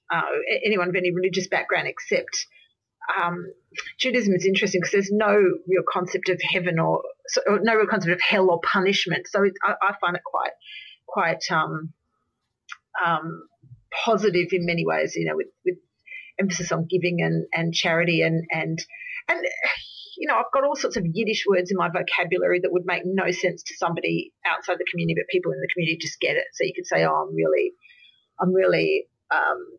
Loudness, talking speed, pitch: -23 LUFS, 190 wpm, 190 Hz